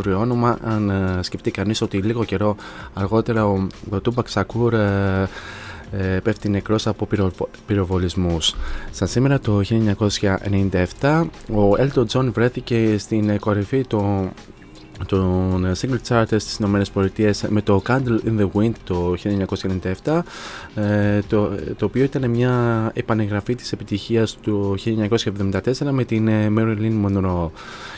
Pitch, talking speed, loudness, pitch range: 105 Hz, 120 wpm, -20 LUFS, 100-115 Hz